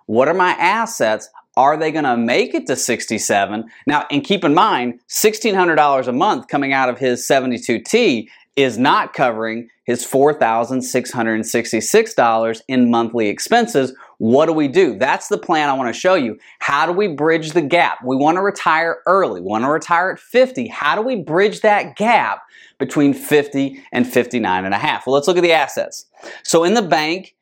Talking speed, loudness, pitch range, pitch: 185 wpm, -16 LUFS, 120-175 Hz, 140 Hz